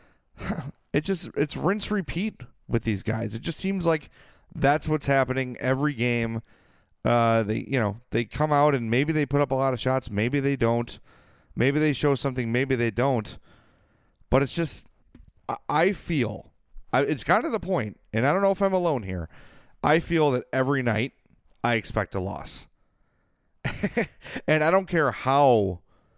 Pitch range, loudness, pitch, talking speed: 115-150 Hz, -25 LUFS, 130 Hz, 175 wpm